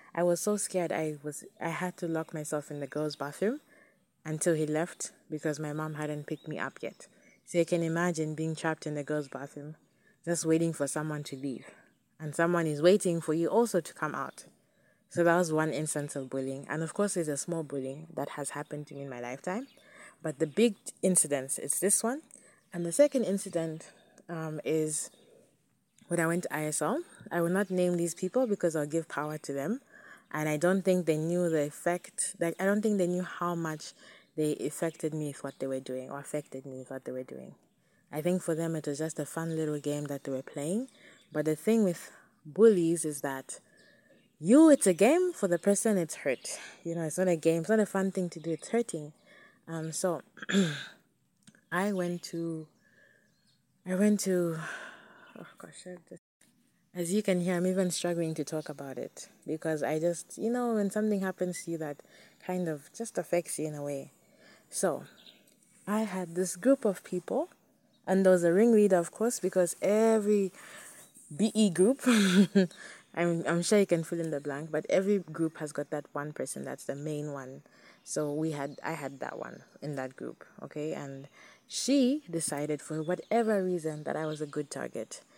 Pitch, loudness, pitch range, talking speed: 170 Hz, -31 LUFS, 150-190 Hz, 200 wpm